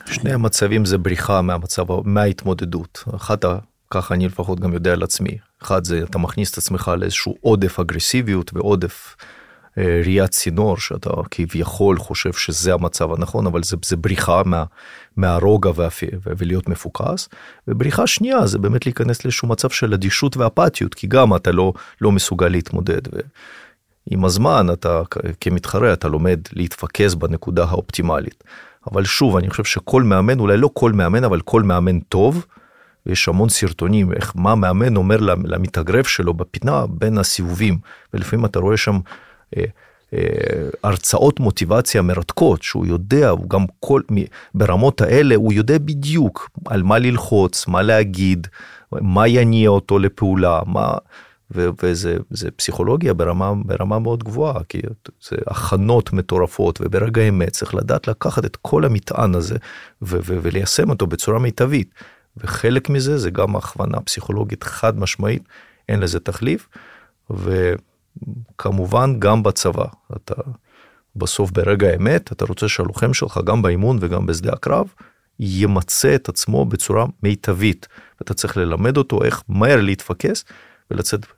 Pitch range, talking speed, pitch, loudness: 90-110 Hz, 140 wpm, 100 Hz, -18 LUFS